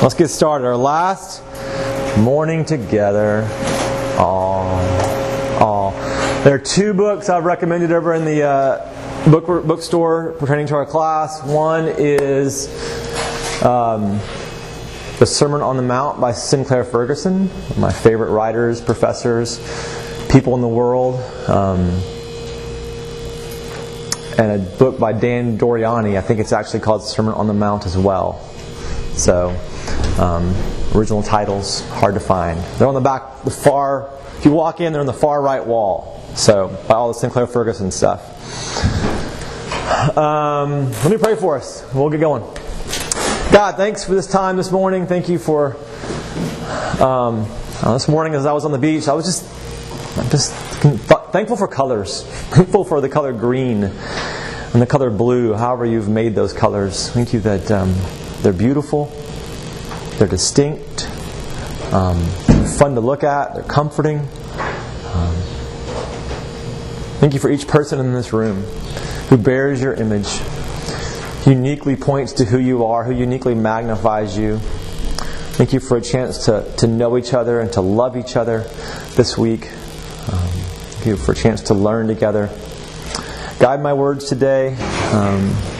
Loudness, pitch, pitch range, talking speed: -17 LUFS, 125 Hz, 110-145 Hz, 150 wpm